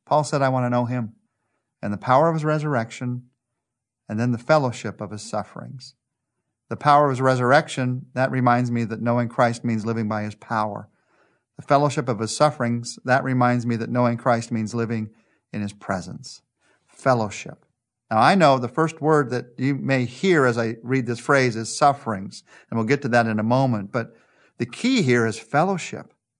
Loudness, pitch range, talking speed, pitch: -22 LUFS, 115-135 Hz, 190 wpm, 120 Hz